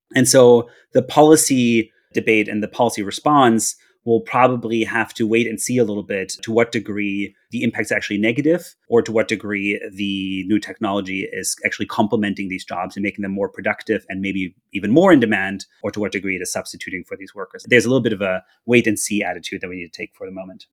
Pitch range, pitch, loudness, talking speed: 100-115 Hz, 110 Hz, -19 LUFS, 225 wpm